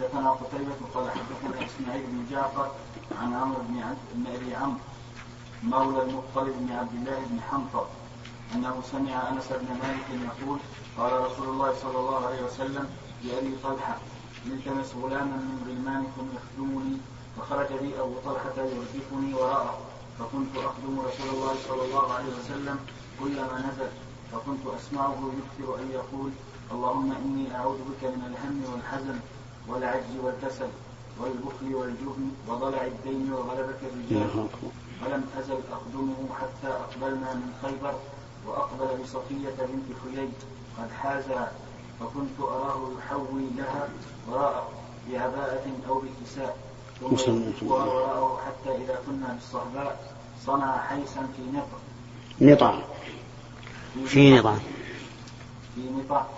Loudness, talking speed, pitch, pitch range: -30 LUFS, 115 wpm, 130 Hz, 125-135 Hz